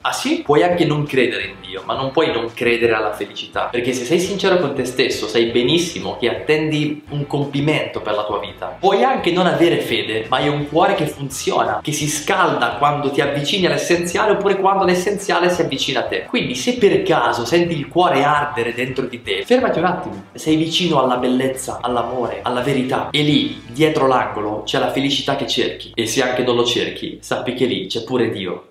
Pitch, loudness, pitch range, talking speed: 145 Hz, -18 LUFS, 120-170 Hz, 205 wpm